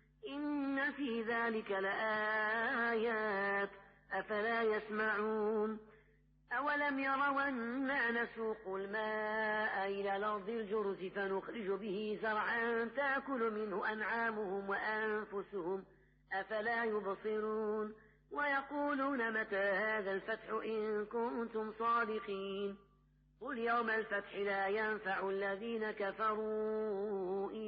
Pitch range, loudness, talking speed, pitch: 200-230 Hz, -38 LUFS, 80 wpm, 215 Hz